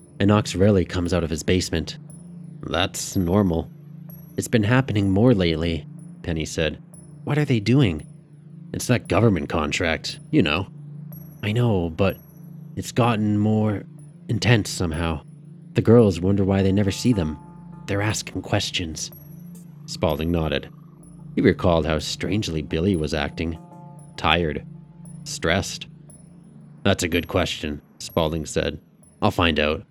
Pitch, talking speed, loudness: 110 Hz, 130 wpm, -22 LUFS